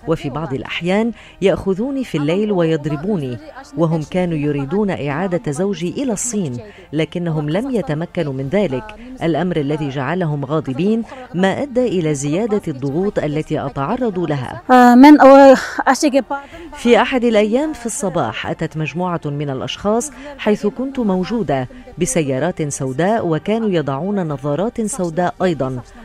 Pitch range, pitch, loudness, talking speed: 155-225 Hz, 180 Hz, -17 LUFS, 115 wpm